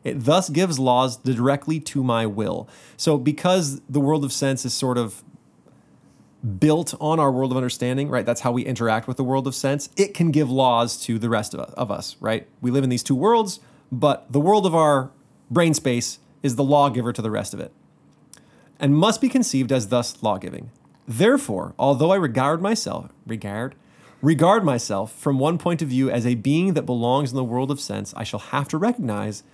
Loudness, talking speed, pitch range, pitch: -21 LUFS, 200 wpm, 120-155 Hz, 135 Hz